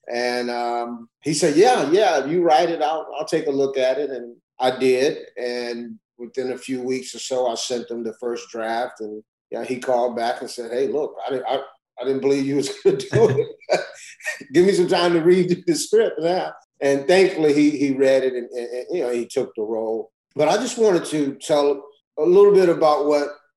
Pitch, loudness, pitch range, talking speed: 135 Hz, -20 LUFS, 120-170 Hz, 230 wpm